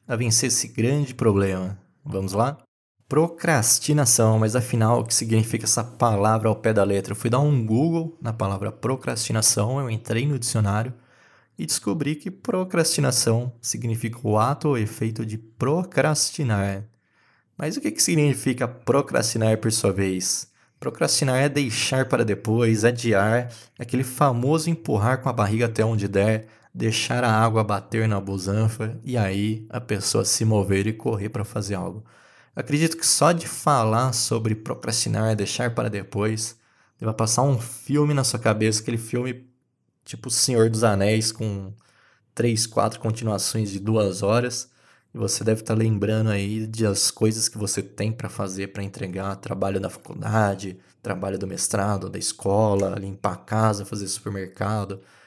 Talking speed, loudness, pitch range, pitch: 155 wpm, -23 LUFS, 105-125 Hz, 110 Hz